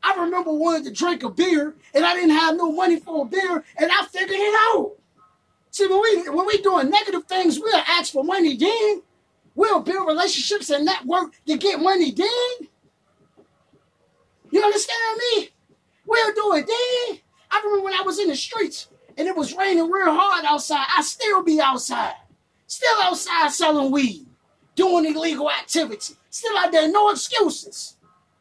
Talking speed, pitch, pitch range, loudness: 175 wpm, 360 Hz, 320-405 Hz, -20 LUFS